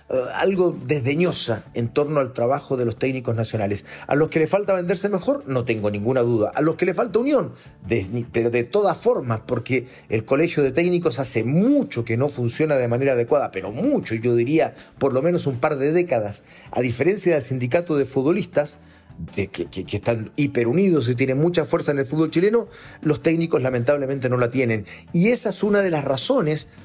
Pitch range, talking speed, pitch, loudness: 120-170 Hz, 200 wpm, 140 Hz, -21 LUFS